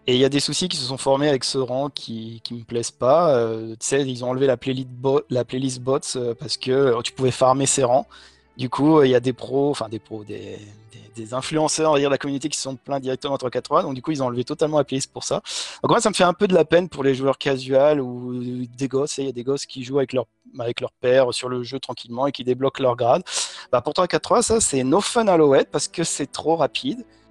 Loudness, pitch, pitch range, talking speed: -21 LUFS, 135 Hz, 125-145 Hz, 290 wpm